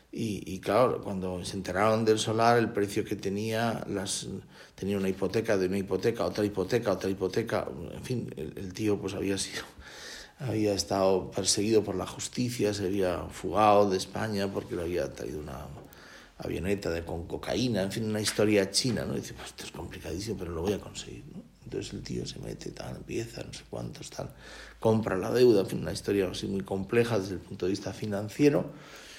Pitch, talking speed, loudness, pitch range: 100 Hz, 195 wpm, -30 LUFS, 95-110 Hz